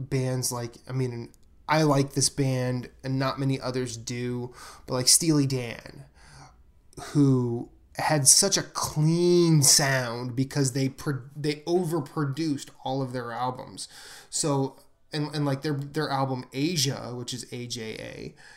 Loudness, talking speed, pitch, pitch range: -25 LUFS, 140 wpm, 135 Hz, 125-150 Hz